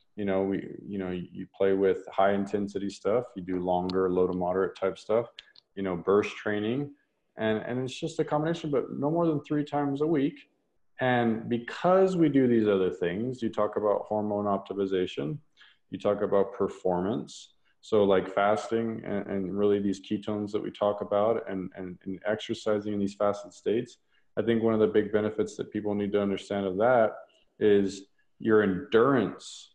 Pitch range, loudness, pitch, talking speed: 95-115 Hz, -28 LUFS, 105 Hz, 180 wpm